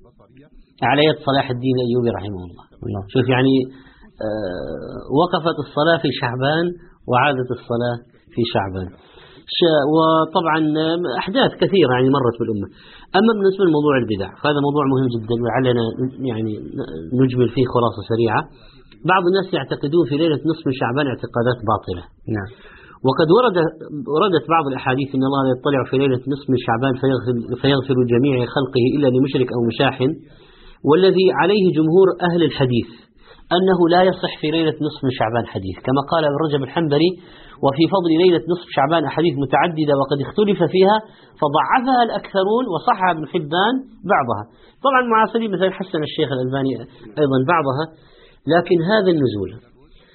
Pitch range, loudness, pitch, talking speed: 125-170 Hz, -18 LUFS, 140 Hz, 135 wpm